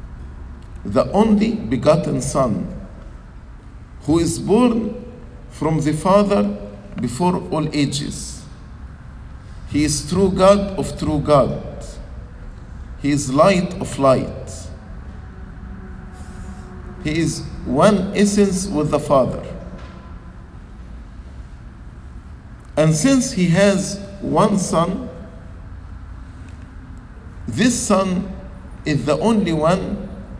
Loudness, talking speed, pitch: -18 LUFS, 85 wpm, 145 Hz